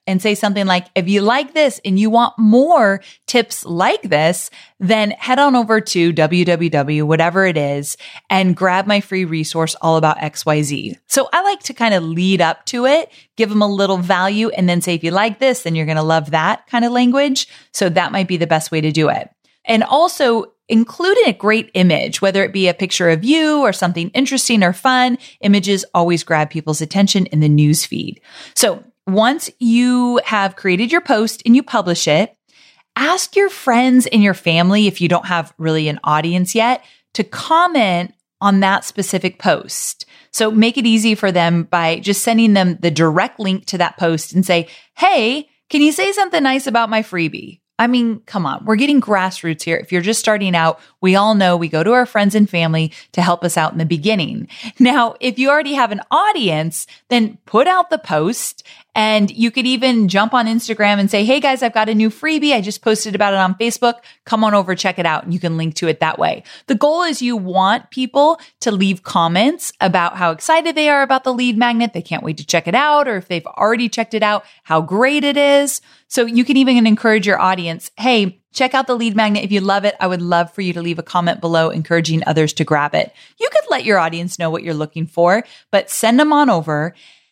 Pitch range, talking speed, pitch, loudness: 175-245 Hz, 220 wpm, 205 Hz, -15 LUFS